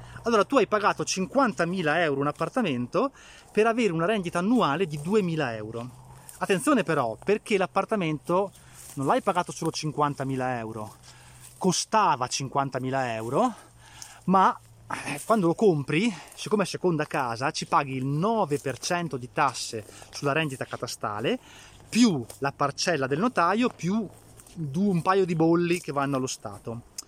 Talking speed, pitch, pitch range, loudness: 135 wpm, 155 Hz, 130-190 Hz, -26 LUFS